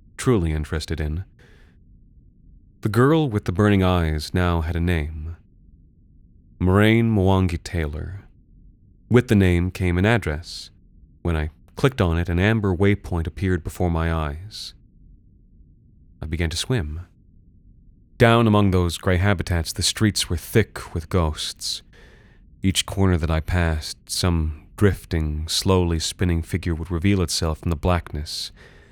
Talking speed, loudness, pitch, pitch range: 135 wpm, -22 LUFS, 90 Hz, 80-100 Hz